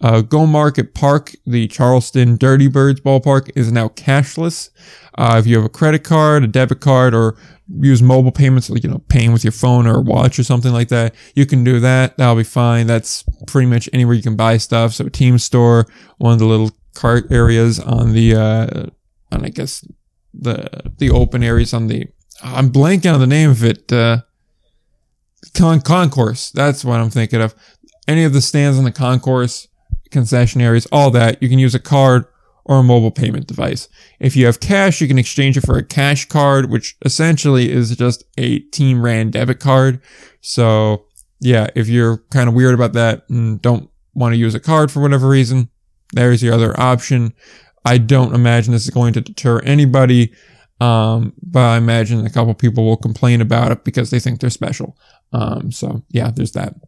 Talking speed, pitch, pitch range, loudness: 195 wpm, 125 Hz, 115-135 Hz, -14 LUFS